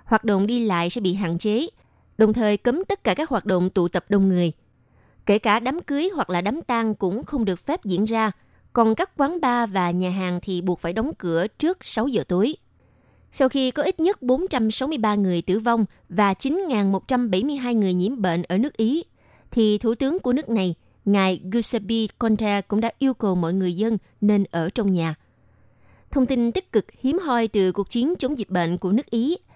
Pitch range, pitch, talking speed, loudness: 185-255 Hz, 220 Hz, 205 wpm, -22 LUFS